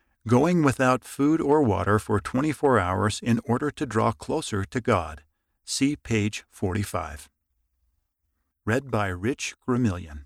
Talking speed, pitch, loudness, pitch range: 140 wpm, 105 Hz, -25 LUFS, 85-130 Hz